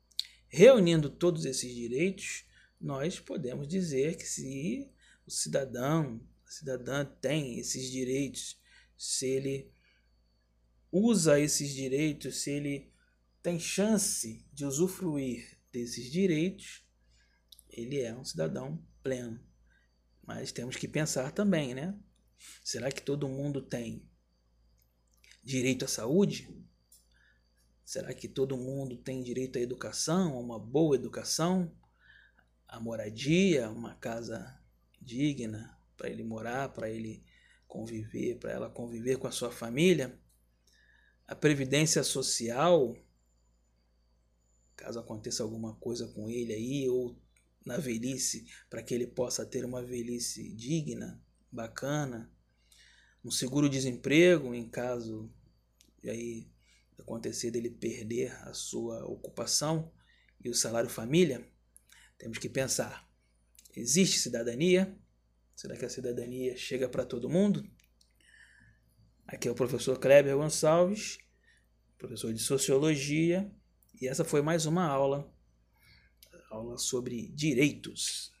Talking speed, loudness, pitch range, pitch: 115 wpm, -32 LUFS, 110-145 Hz, 125 Hz